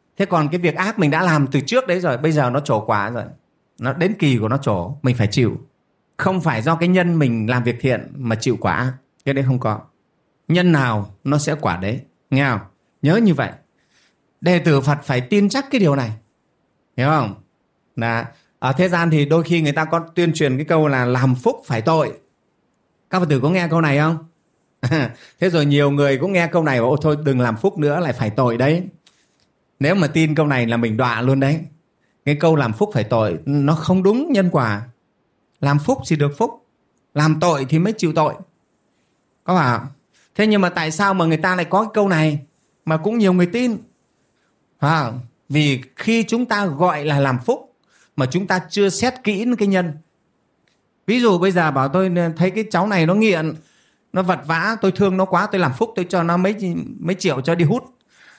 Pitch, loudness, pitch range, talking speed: 160 Hz, -18 LUFS, 135-185 Hz, 220 wpm